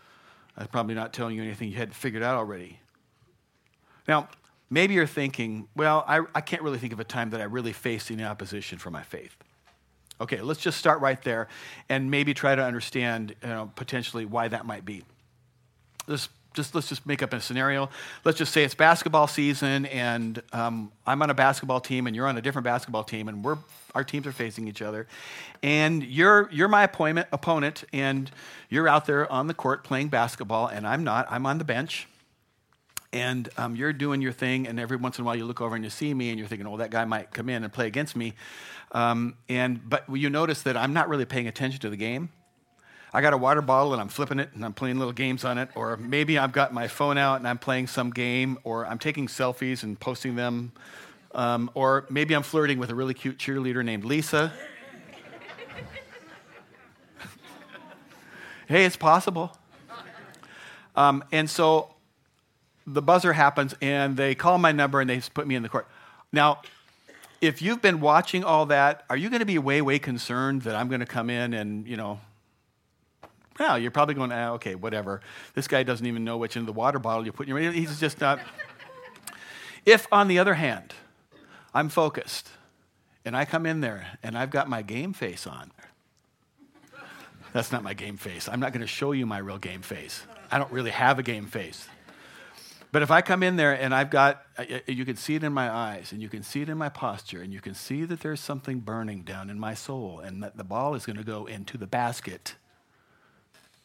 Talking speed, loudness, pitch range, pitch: 210 wpm, -26 LUFS, 115-145 Hz, 130 Hz